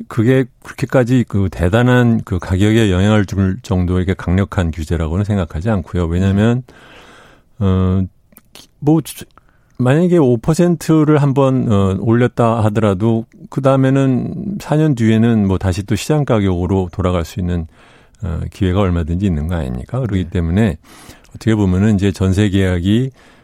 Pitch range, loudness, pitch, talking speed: 95-125 Hz, -15 LUFS, 105 Hz, 295 characters per minute